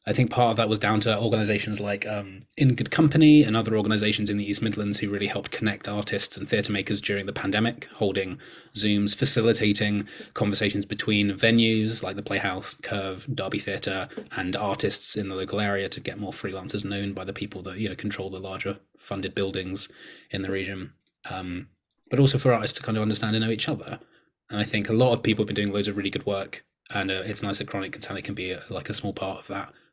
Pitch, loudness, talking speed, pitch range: 105 Hz, -25 LUFS, 225 wpm, 100-110 Hz